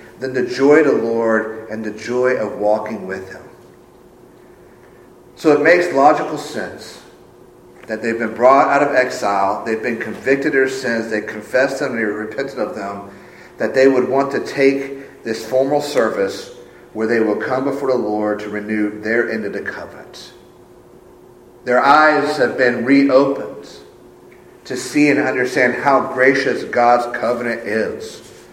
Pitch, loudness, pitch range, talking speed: 115 Hz, -17 LUFS, 110-135 Hz, 160 wpm